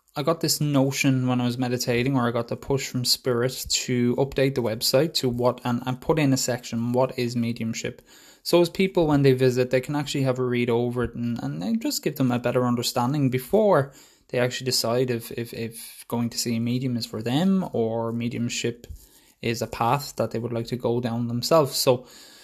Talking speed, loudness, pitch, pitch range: 220 wpm, -24 LUFS, 125 Hz, 120-135 Hz